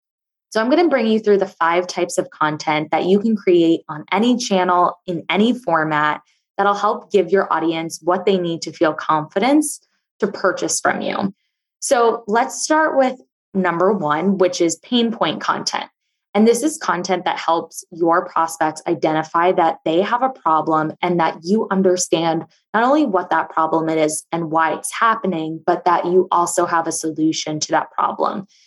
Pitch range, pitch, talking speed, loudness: 160-205 Hz, 175 Hz, 180 wpm, -18 LUFS